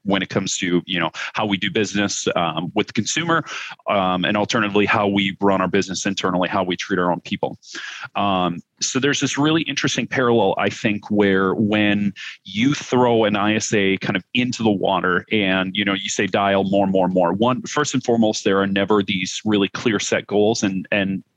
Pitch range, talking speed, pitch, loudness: 95-110 Hz, 200 wpm, 100 Hz, -20 LUFS